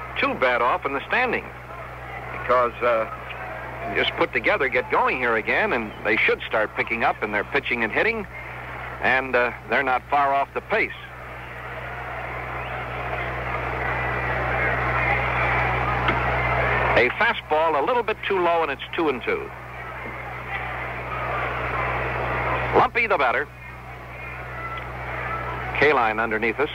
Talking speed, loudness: 120 wpm, -23 LUFS